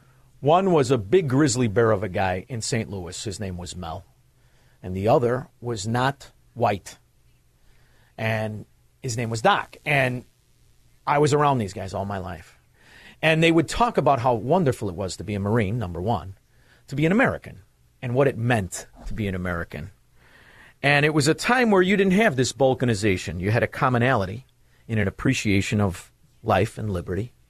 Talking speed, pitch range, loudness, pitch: 185 wpm, 100-135 Hz, -23 LUFS, 120 Hz